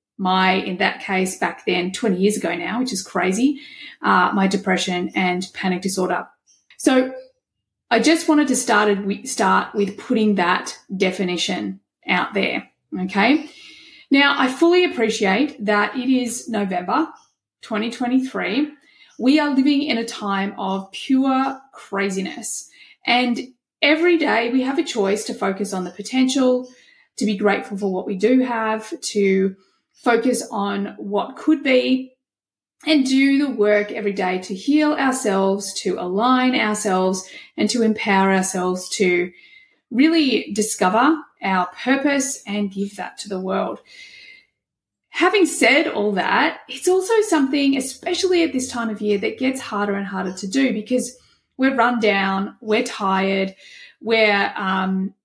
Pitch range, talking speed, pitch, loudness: 195-275 Hz, 145 wpm, 230 Hz, -20 LUFS